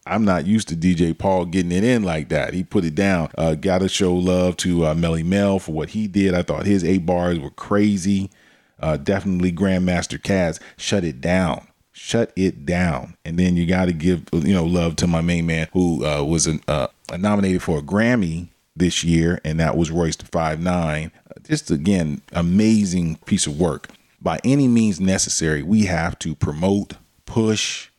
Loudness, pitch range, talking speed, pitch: -20 LUFS, 80-100 Hz, 190 wpm, 90 Hz